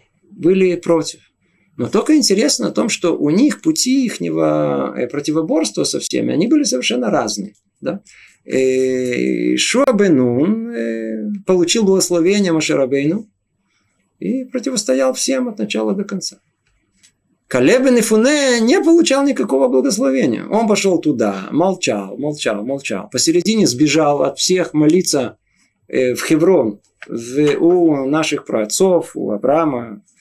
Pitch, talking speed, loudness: 165 Hz, 115 wpm, -16 LUFS